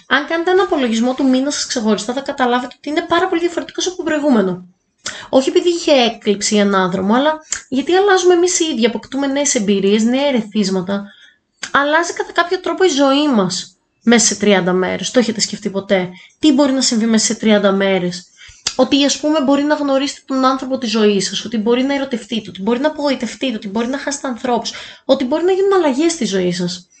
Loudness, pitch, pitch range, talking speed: -15 LUFS, 260 Hz, 210-300 Hz, 200 wpm